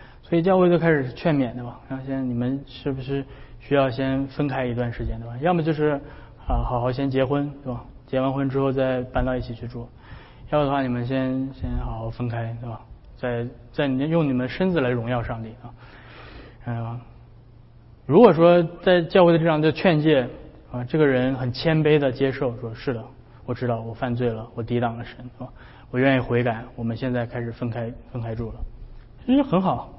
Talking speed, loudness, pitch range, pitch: 280 characters per minute, -23 LUFS, 120-140 Hz, 125 Hz